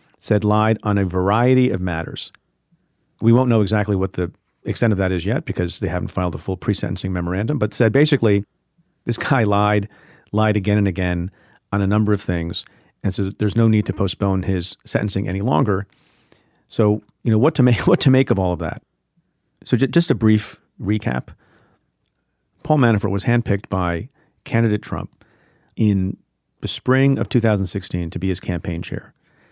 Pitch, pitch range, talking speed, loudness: 105 Hz, 95-115 Hz, 175 wpm, -20 LUFS